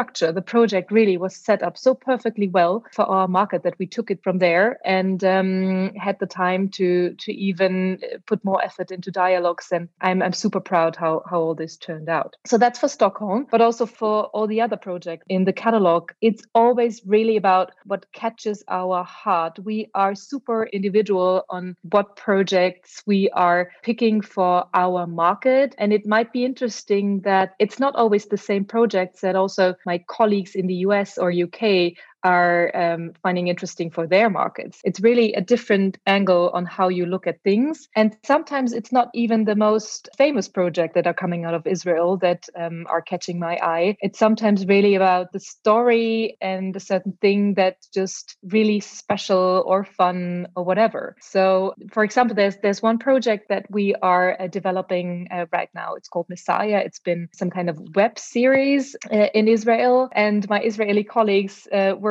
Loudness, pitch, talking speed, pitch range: -21 LUFS, 195 Hz, 185 wpm, 180-215 Hz